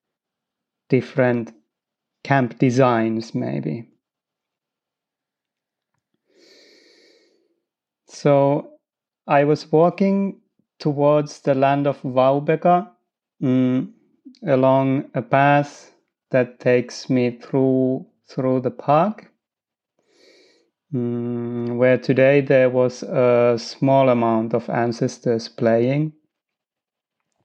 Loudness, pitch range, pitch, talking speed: -19 LUFS, 125-190 Hz, 140 Hz, 75 wpm